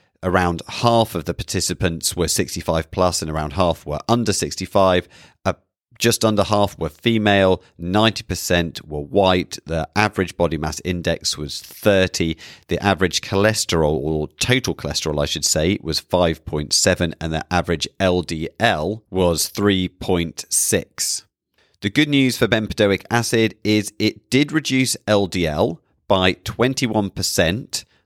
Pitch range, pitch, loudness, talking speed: 85-105 Hz, 95 Hz, -20 LUFS, 130 wpm